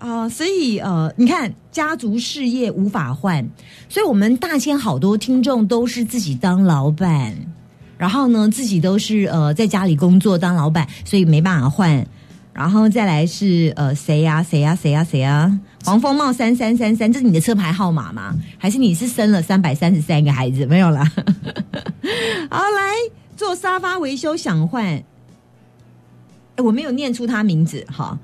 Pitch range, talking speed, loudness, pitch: 160-240 Hz, 265 characters per minute, -17 LUFS, 195 Hz